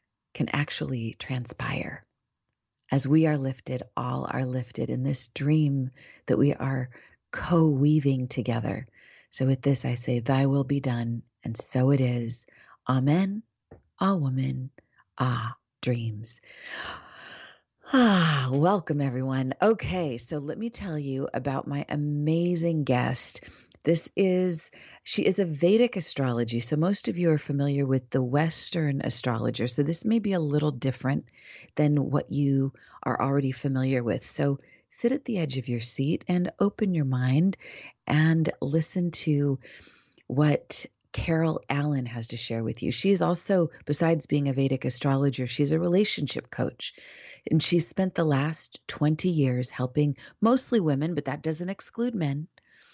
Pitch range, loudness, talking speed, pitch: 130-165 Hz, -27 LUFS, 145 wpm, 140 Hz